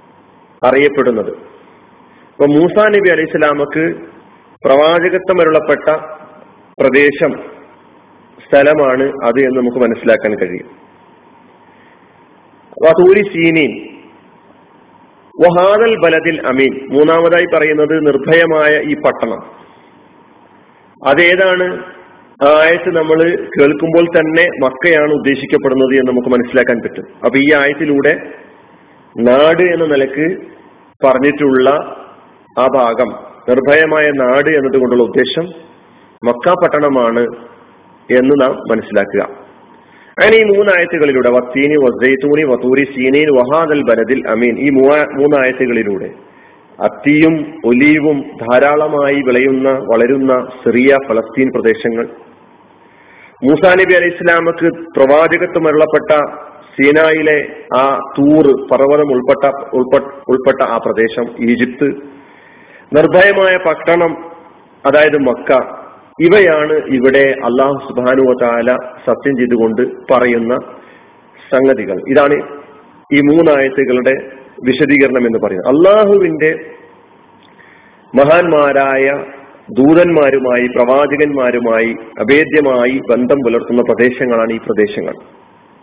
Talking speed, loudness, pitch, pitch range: 80 wpm, -11 LUFS, 145 Hz, 130-160 Hz